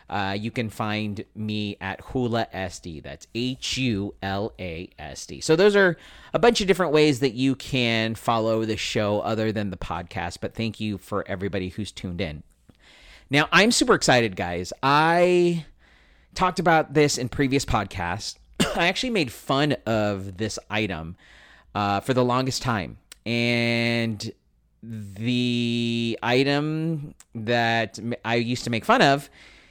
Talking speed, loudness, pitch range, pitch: 155 wpm, -24 LUFS, 100-130 Hz, 115 Hz